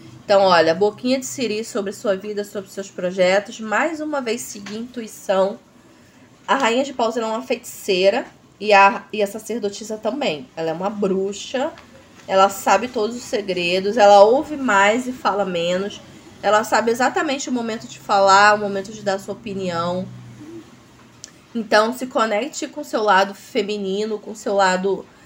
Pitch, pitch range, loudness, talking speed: 205 Hz, 195-230 Hz, -19 LUFS, 165 wpm